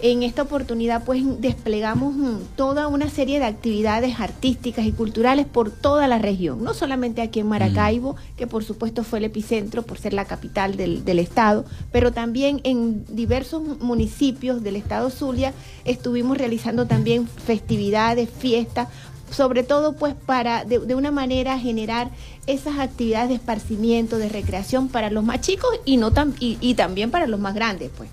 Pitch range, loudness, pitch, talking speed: 220-260 Hz, -22 LUFS, 235 Hz, 165 wpm